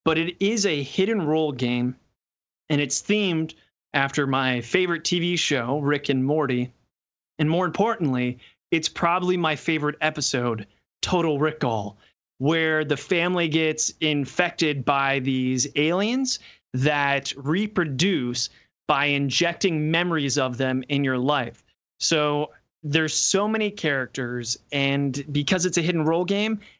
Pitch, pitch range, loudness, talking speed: 150 Hz, 135-170 Hz, -23 LUFS, 130 wpm